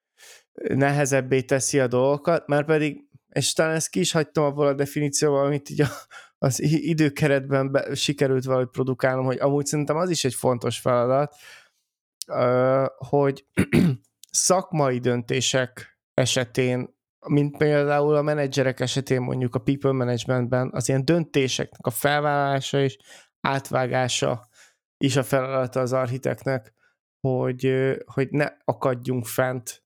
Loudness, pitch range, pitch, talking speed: -23 LUFS, 130-145 Hz, 135 Hz, 125 wpm